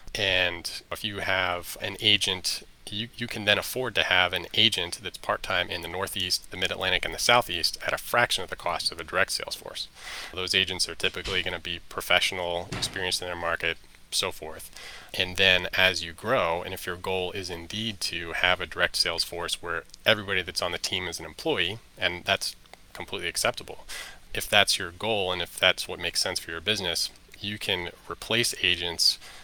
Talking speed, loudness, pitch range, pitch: 200 wpm, -26 LUFS, 85-95 Hz, 90 Hz